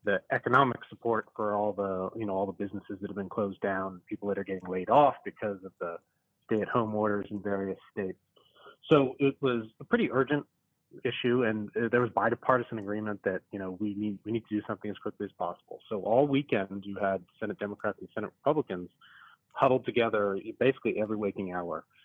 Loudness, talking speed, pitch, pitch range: -31 LUFS, 200 wpm, 105 Hz, 100-115 Hz